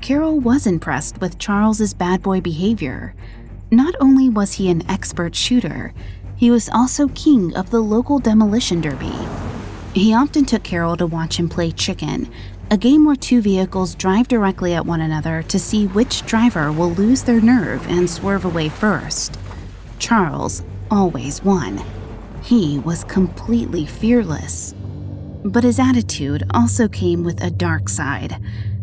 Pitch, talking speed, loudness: 175 Hz, 150 wpm, -17 LUFS